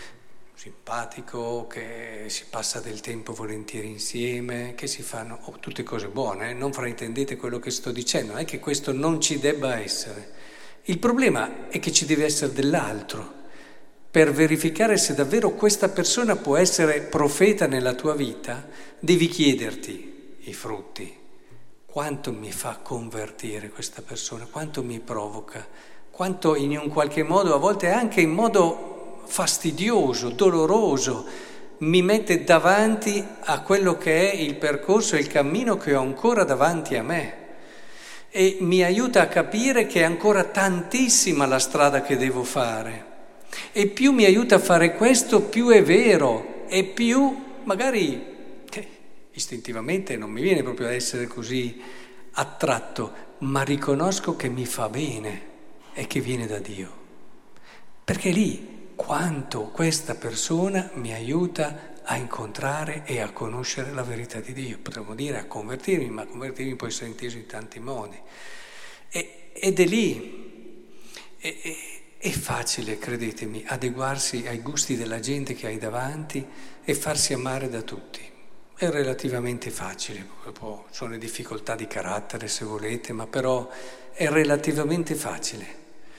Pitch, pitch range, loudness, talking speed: 140 Hz, 120-175 Hz, -24 LUFS, 145 wpm